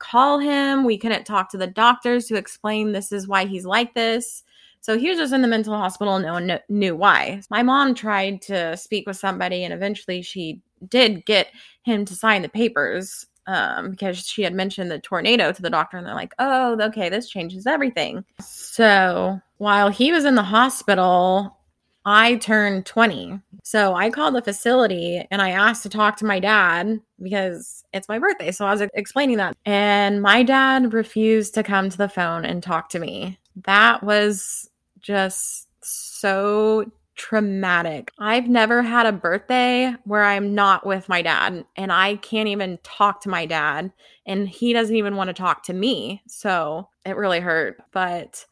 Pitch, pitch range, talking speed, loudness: 205 Hz, 190-225 Hz, 185 wpm, -20 LUFS